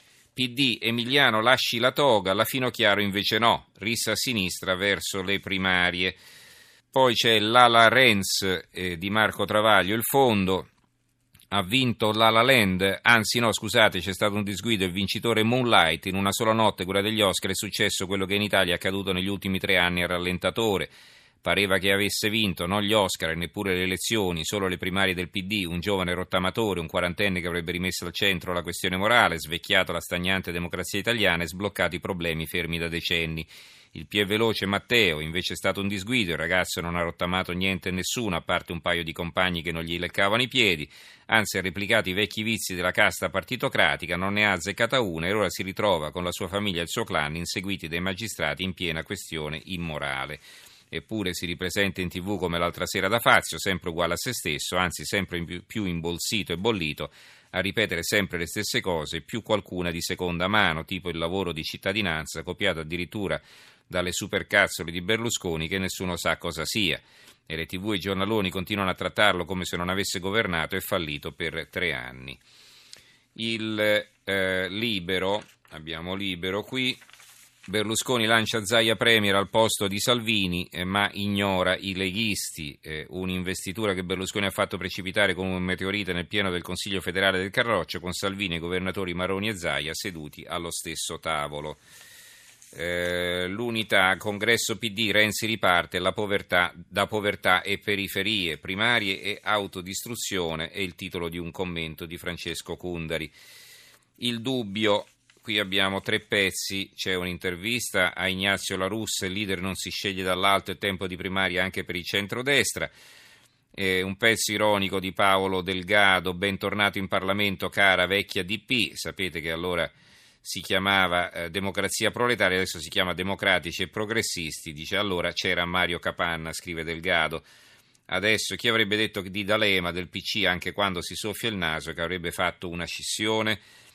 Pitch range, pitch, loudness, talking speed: 90-105 Hz, 95 Hz, -25 LUFS, 170 wpm